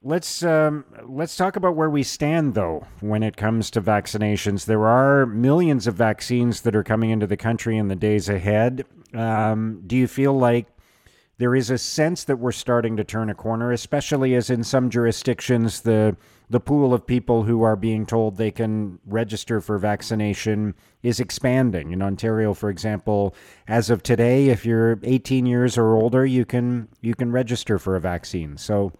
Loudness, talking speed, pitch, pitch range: -21 LUFS, 180 wpm, 115 Hz, 105-125 Hz